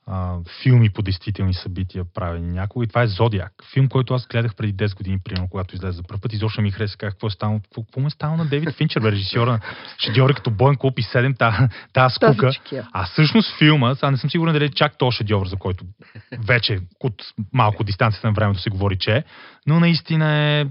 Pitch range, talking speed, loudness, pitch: 100-135 Hz, 215 wpm, -20 LUFS, 115 Hz